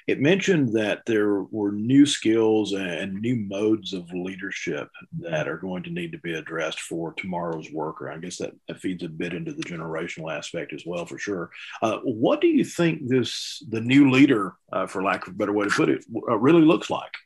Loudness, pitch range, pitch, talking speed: -24 LUFS, 100-145 Hz, 110 Hz, 210 wpm